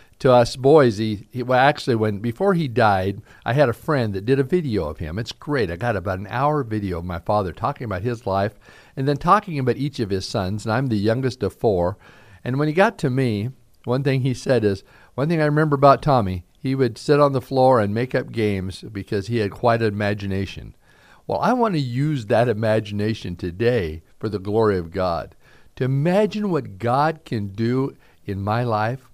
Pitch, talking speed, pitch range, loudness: 120 Hz, 215 wpm, 105-135 Hz, -21 LUFS